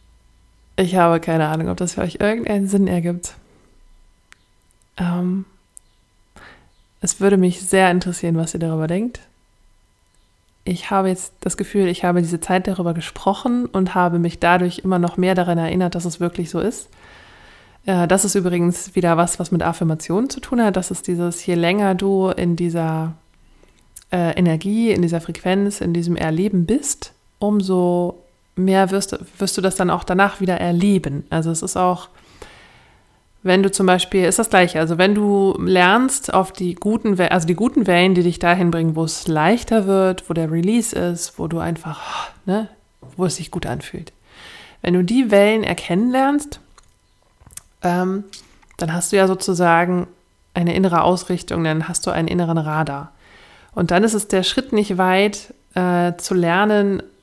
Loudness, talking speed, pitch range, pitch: -18 LUFS, 170 wpm, 170-195 Hz, 180 Hz